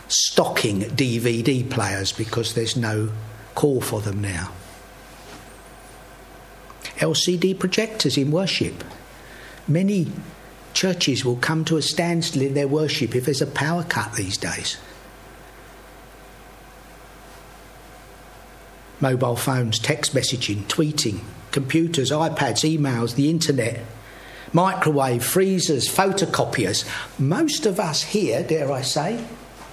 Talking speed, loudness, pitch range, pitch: 105 wpm, -22 LUFS, 115-160 Hz, 140 Hz